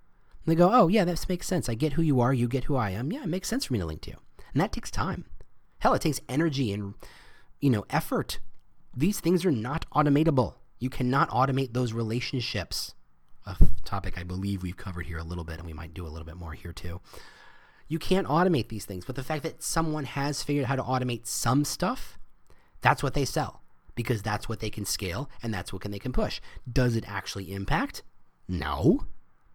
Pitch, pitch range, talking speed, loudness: 125 Hz, 100-150 Hz, 220 wpm, -28 LUFS